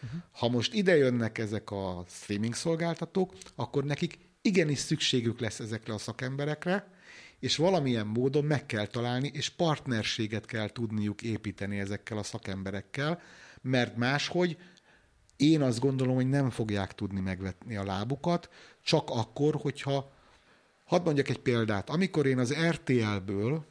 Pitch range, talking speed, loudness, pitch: 110-150 Hz, 135 wpm, -31 LUFS, 130 Hz